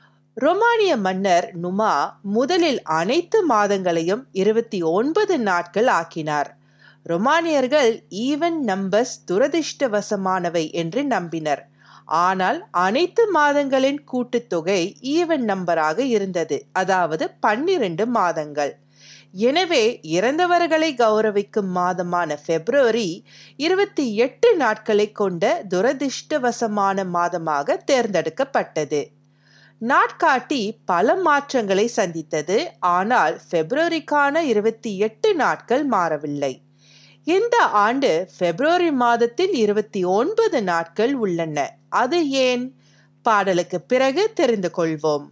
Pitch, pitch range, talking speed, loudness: 215 Hz, 175-285 Hz, 85 wpm, -20 LUFS